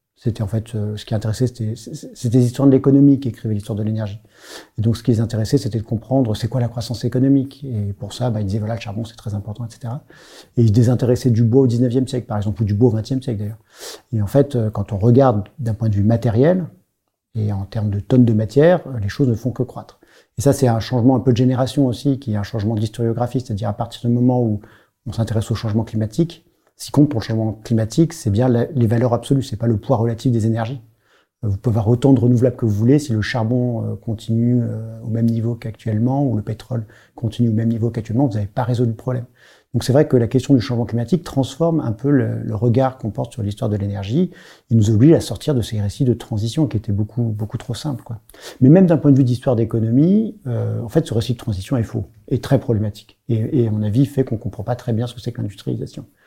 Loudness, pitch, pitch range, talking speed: -19 LUFS, 115 Hz, 110-130 Hz, 250 wpm